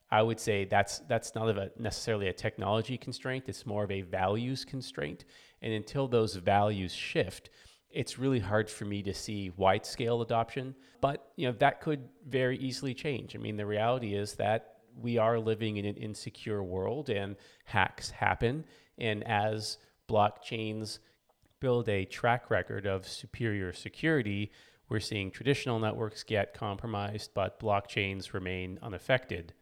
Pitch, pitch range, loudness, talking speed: 110 Hz, 100-120 Hz, -33 LUFS, 155 wpm